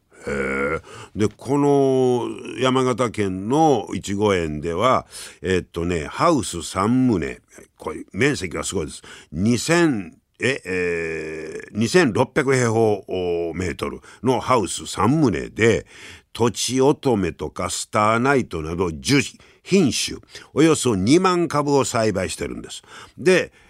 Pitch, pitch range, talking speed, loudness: 105 Hz, 85-130 Hz, 210 characters per minute, -21 LUFS